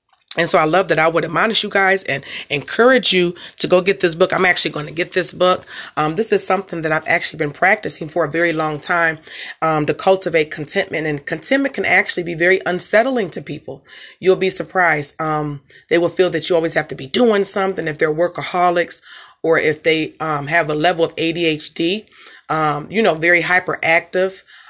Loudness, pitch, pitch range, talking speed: -17 LUFS, 170 Hz, 155-185 Hz, 205 wpm